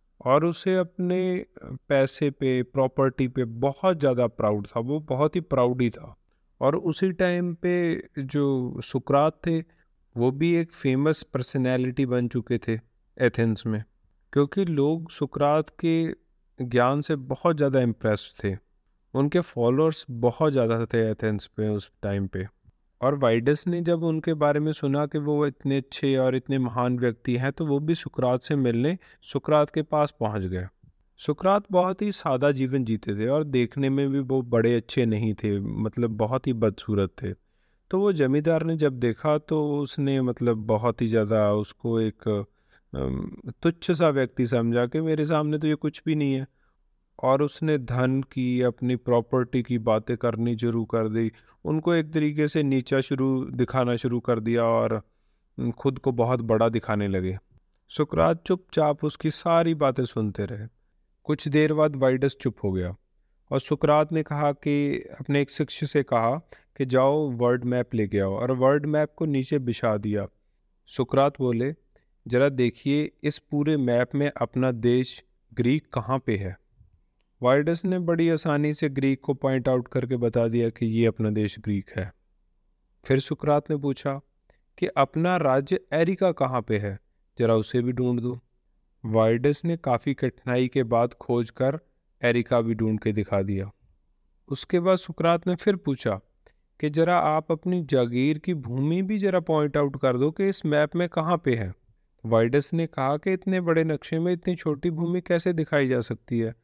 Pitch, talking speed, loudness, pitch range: 135 Hz, 170 wpm, -25 LUFS, 120-150 Hz